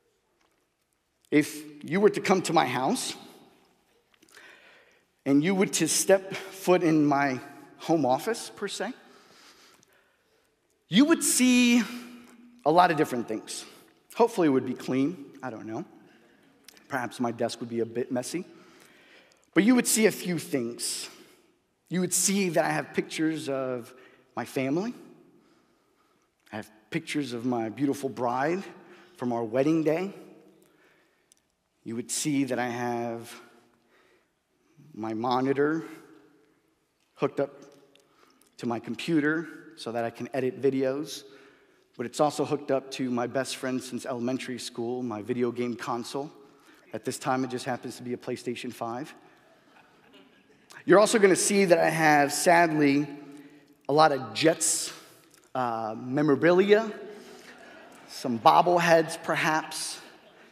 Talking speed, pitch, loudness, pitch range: 135 wpm, 145 Hz, -26 LUFS, 125-175 Hz